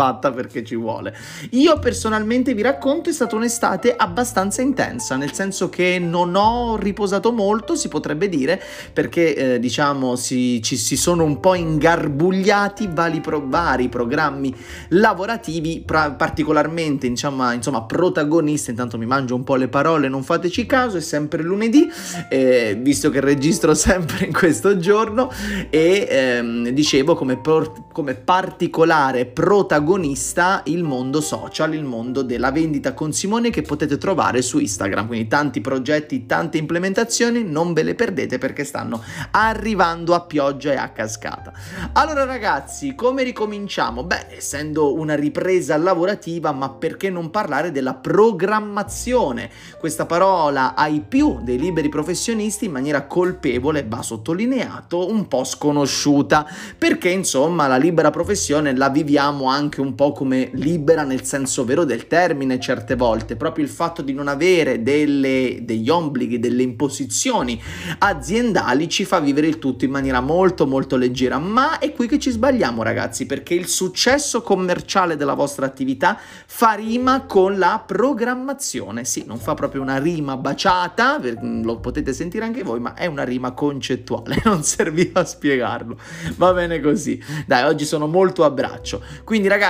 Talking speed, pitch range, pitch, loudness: 150 wpm, 135-195 Hz, 155 Hz, -19 LUFS